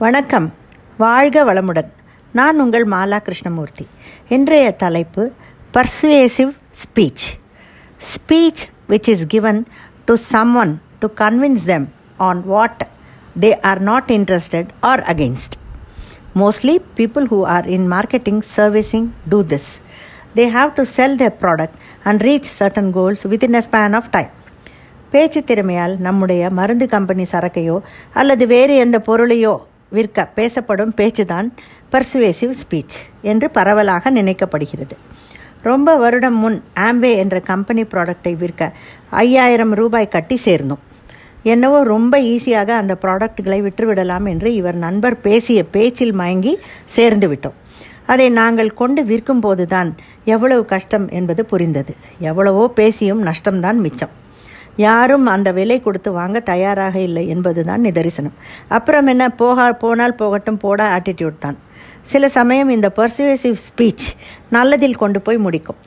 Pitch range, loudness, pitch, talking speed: 185-240 Hz, -14 LUFS, 215 Hz, 125 wpm